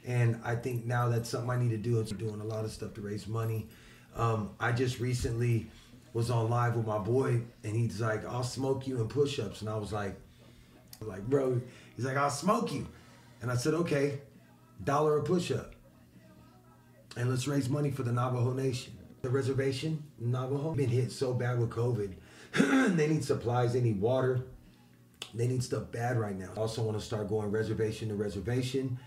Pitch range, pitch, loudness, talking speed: 110-130 Hz, 120 Hz, -32 LUFS, 190 wpm